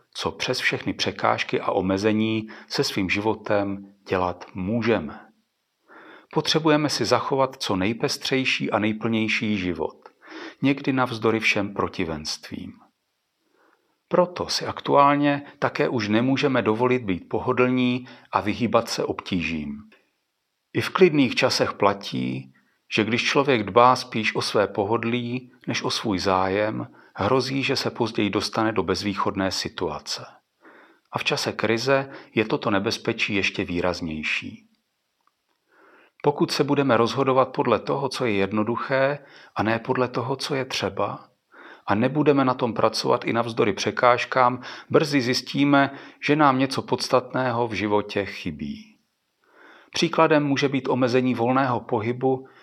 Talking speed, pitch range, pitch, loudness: 125 wpm, 105-135 Hz, 125 Hz, -23 LUFS